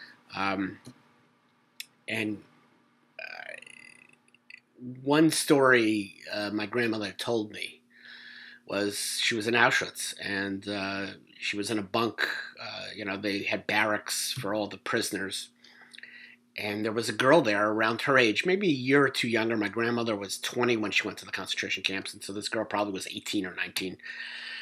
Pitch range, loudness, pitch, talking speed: 100-120 Hz, -28 LUFS, 105 Hz, 165 wpm